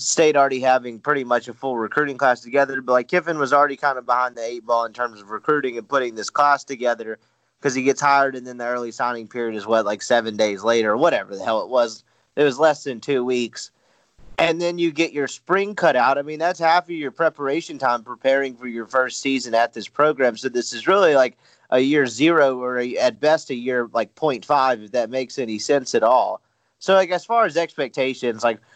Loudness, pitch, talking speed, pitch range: -20 LUFS, 130 Hz, 235 wpm, 120-145 Hz